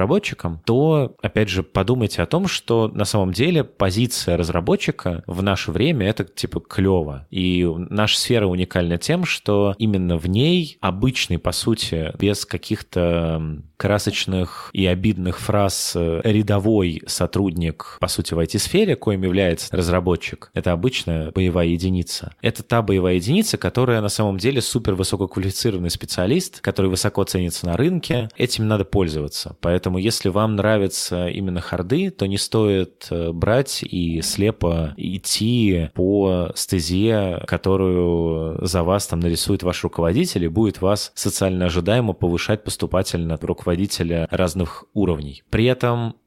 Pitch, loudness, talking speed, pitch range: 95 Hz, -20 LUFS, 135 wpm, 90-110 Hz